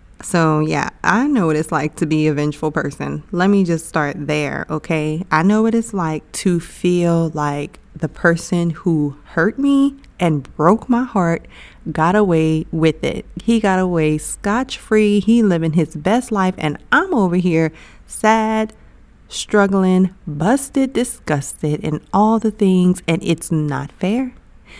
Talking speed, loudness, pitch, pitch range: 155 wpm, -17 LUFS, 175 Hz, 155-210 Hz